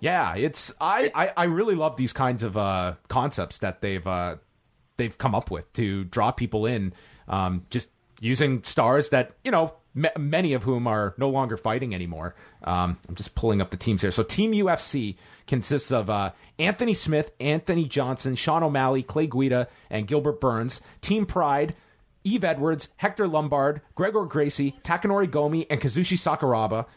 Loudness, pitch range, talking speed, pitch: -25 LUFS, 110-155 Hz, 170 wpm, 130 Hz